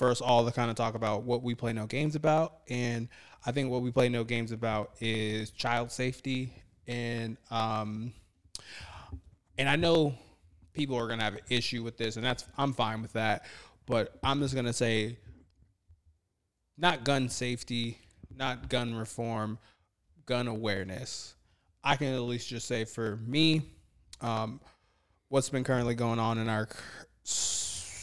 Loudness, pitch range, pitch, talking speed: -32 LUFS, 105-125 Hz, 115 Hz, 160 wpm